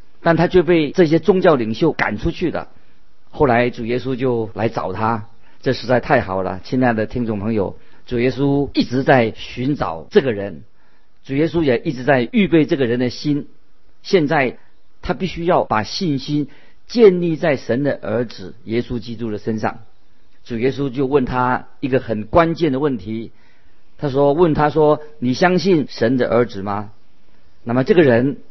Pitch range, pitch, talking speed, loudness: 115-155 Hz, 130 Hz, 245 characters per minute, -18 LUFS